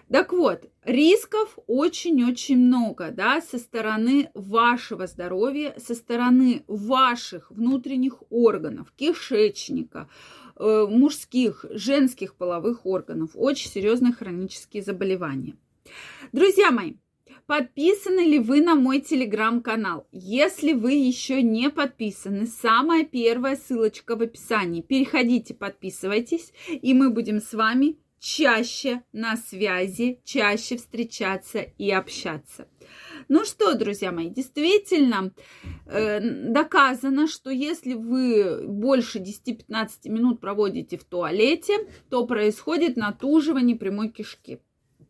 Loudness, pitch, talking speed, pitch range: -23 LUFS, 245 Hz, 100 wpm, 215-280 Hz